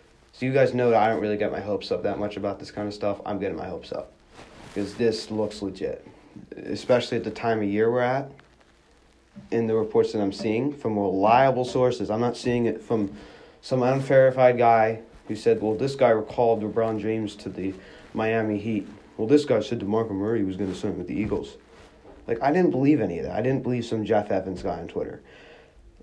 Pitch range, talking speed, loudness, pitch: 105-125 Hz, 215 wpm, -25 LUFS, 110 Hz